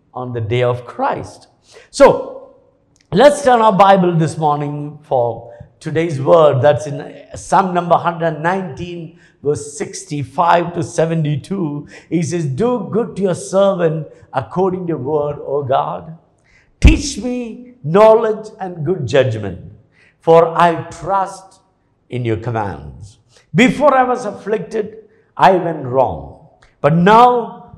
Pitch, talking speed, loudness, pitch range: 170 Hz, 125 wpm, -15 LUFS, 145-195 Hz